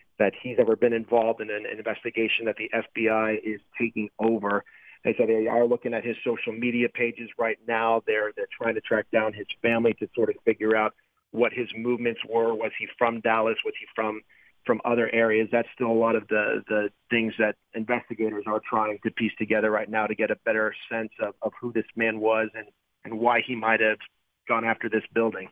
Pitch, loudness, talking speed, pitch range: 115 Hz, -26 LUFS, 215 wpm, 110-115 Hz